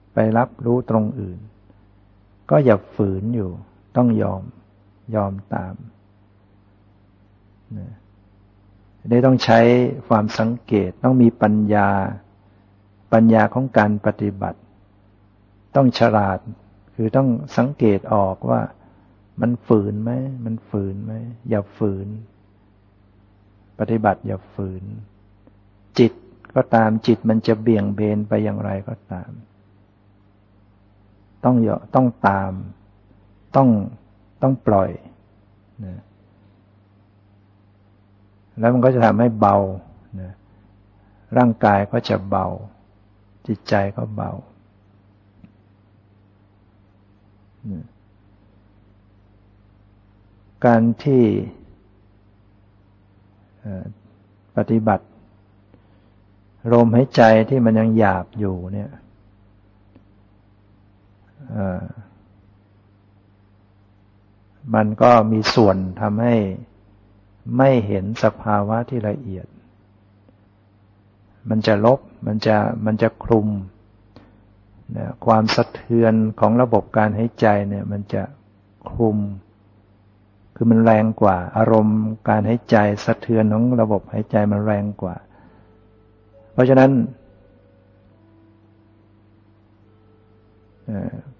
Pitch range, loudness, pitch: 100-110 Hz, -18 LUFS, 100 Hz